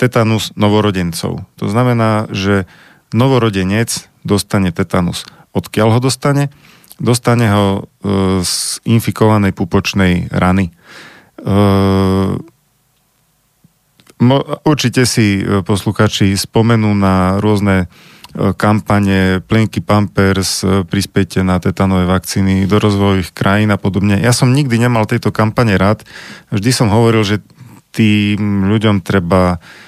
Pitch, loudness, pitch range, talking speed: 105 Hz, -13 LUFS, 95-120 Hz, 110 wpm